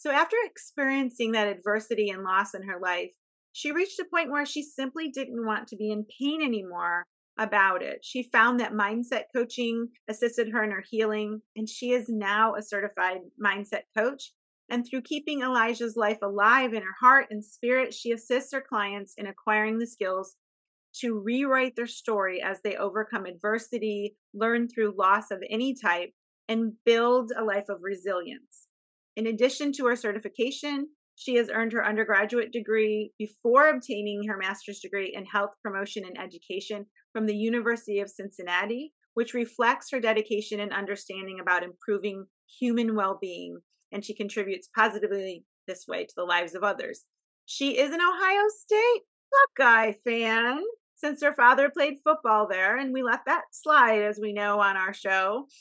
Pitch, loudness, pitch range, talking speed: 220 Hz, -27 LUFS, 200-250 Hz, 165 wpm